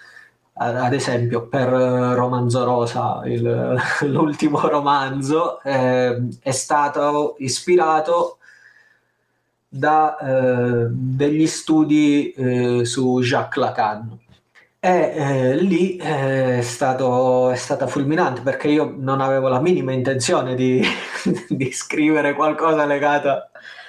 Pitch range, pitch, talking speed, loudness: 125-150 Hz, 135 Hz, 105 wpm, -19 LUFS